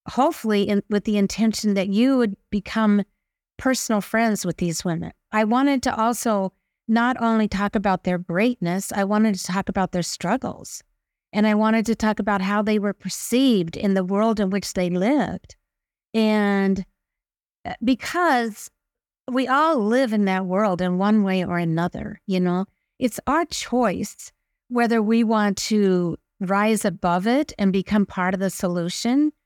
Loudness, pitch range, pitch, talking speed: -22 LUFS, 190-230 Hz, 205 Hz, 160 wpm